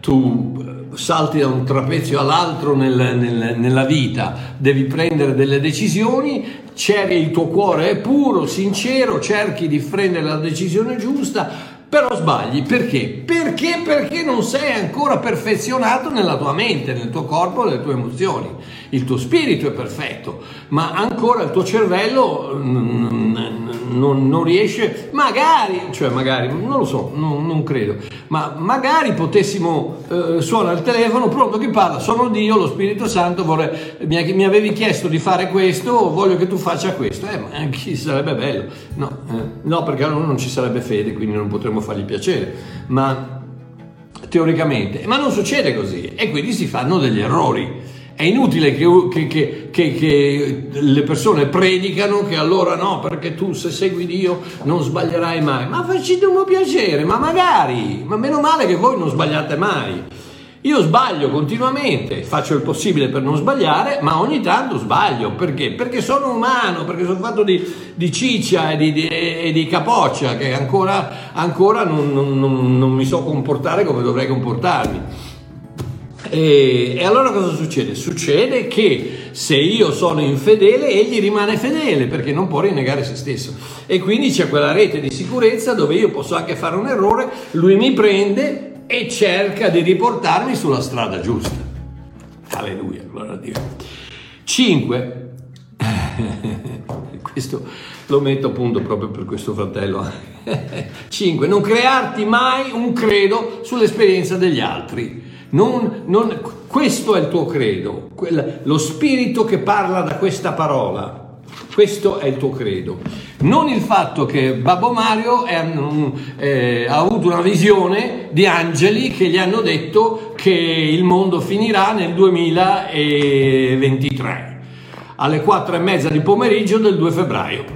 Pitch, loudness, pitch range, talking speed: 170 Hz, -16 LUFS, 140-210 Hz, 150 wpm